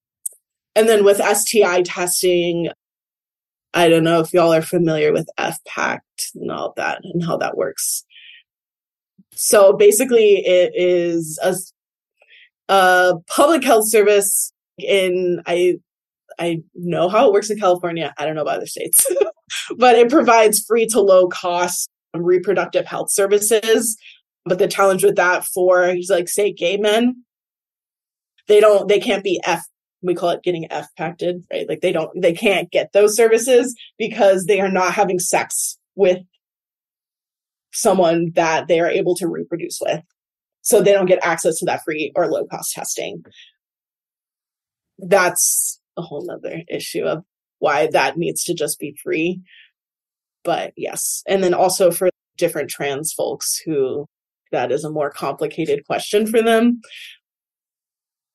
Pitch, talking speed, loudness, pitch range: 190 Hz, 145 wpm, -17 LUFS, 175-220 Hz